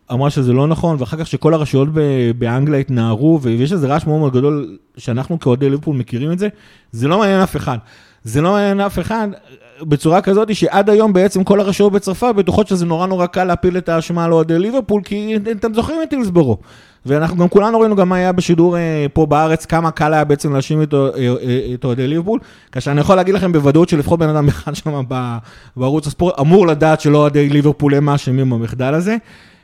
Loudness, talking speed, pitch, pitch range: -15 LUFS, 180 wpm, 160 Hz, 140-190 Hz